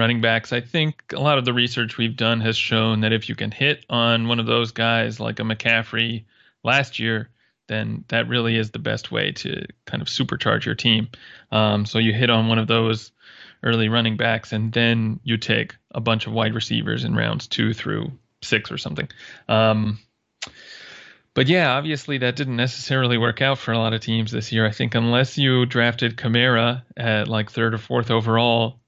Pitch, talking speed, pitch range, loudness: 115 Hz, 200 wpm, 110-120 Hz, -21 LUFS